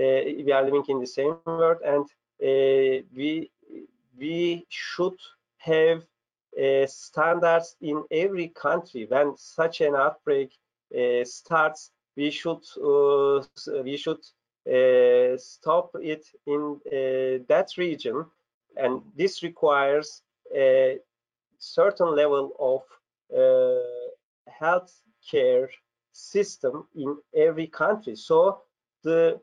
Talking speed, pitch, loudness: 105 wpm, 165 Hz, -25 LUFS